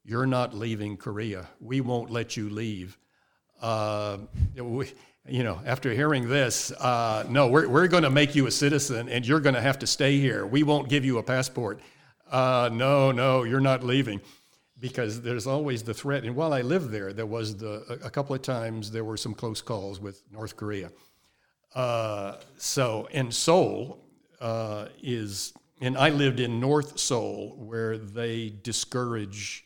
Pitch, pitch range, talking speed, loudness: 120 Hz, 110-135 Hz, 175 wpm, -27 LUFS